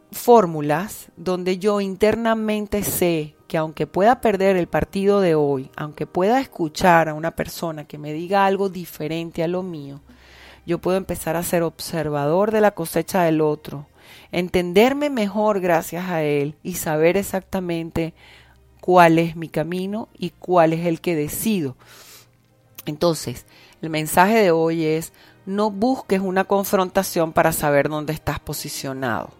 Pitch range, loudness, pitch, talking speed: 155-195 Hz, -20 LUFS, 170 Hz, 145 wpm